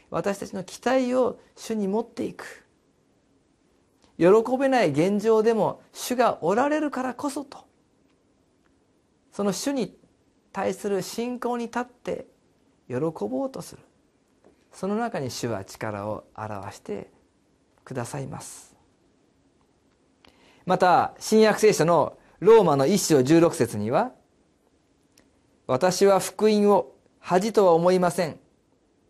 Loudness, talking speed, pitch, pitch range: -23 LUFS, 205 characters per minute, 205 Hz, 175-240 Hz